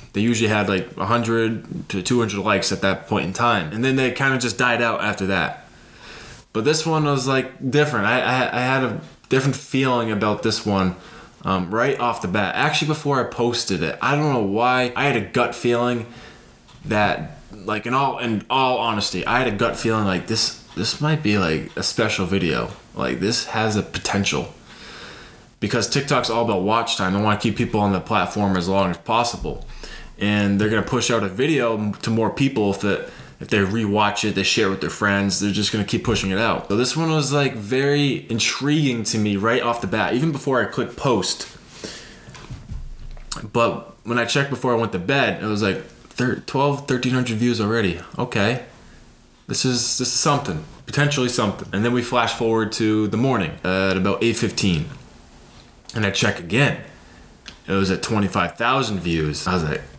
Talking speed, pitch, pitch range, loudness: 195 wpm, 115 Hz, 100-125 Hz, -21 LUFS